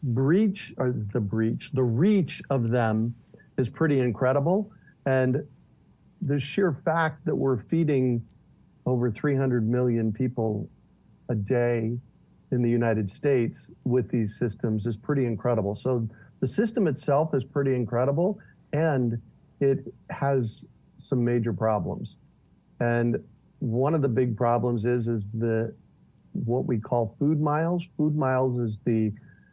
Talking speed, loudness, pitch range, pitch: 135 wpm, -26 LUFS, 115-145 Hz, 125 Hz